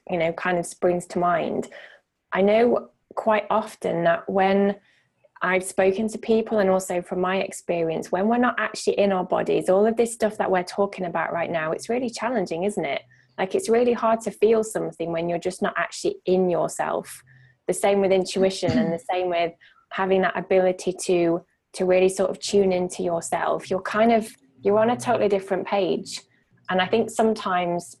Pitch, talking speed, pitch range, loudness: 190 Hz, 195 wpm, 175-210 Hz, -23 LUFS